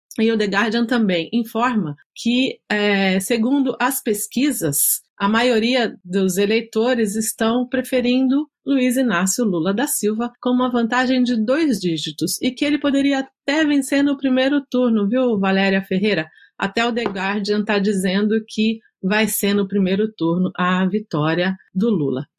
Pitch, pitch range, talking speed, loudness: 220 Hz, 195-255 Hz, 150 wpm, -19 LUFS